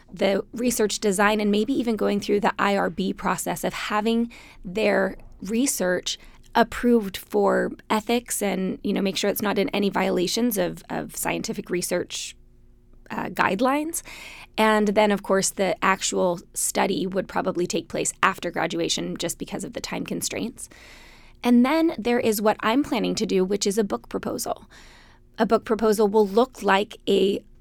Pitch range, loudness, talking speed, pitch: 195-230 Hz, -24 LUFS, 160 wpm, 210 Hz